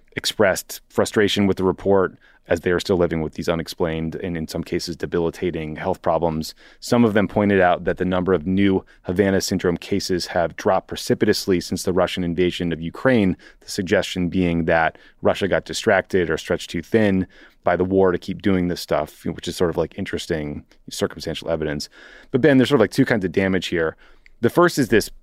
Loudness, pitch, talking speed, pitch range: -21 LUFS, 90 Hz, 200 wpm, 85-95 Hz